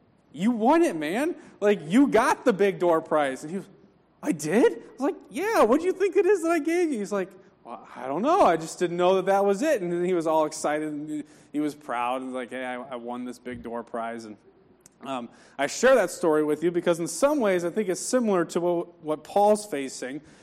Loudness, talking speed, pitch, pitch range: -25 LUFS, 245 wpm, 175 Hz, 150-220 Hz